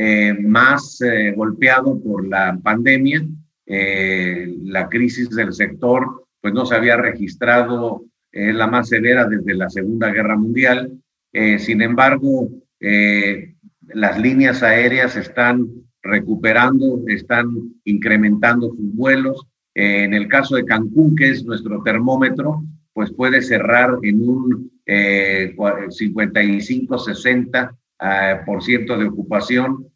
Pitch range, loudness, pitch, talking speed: 105-125 Hz, -16 LUFS, 115 Hz, 120 wpm